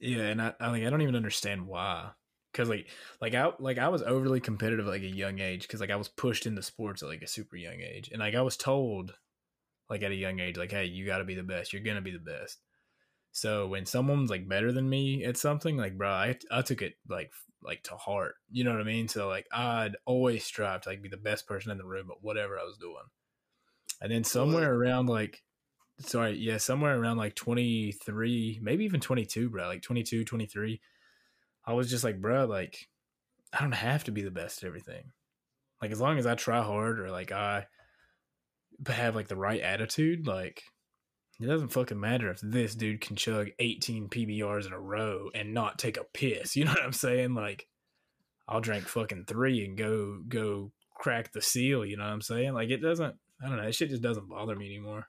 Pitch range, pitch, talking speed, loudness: 100-125 Hz, 115 Hz, 225 wpm, -32 LUFS